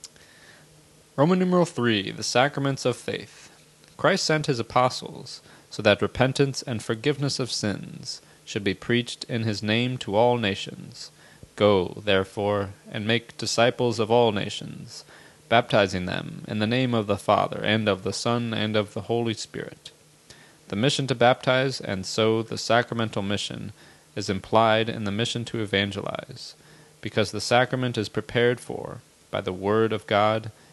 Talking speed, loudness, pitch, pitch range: 155 wpm, -24 LUFS, 115 Hz, 105-125 Hz